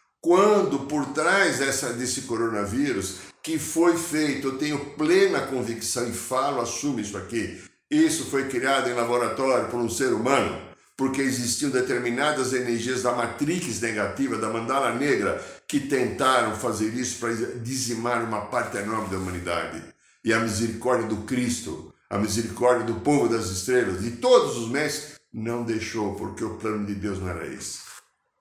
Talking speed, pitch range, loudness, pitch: 155 wpm, 110-135 Hz, -25 LUFS, 120 Hz